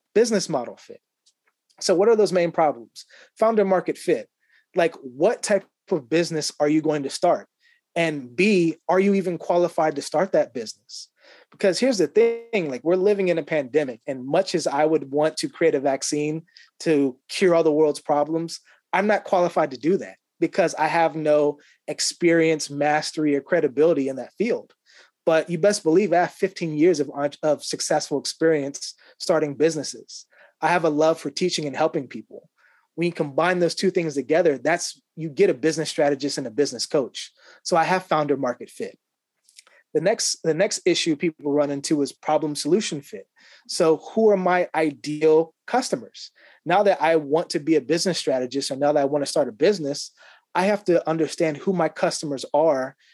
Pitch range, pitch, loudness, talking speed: 150-185 Hz, 160 Hz, -22 LUFS, 185 wpm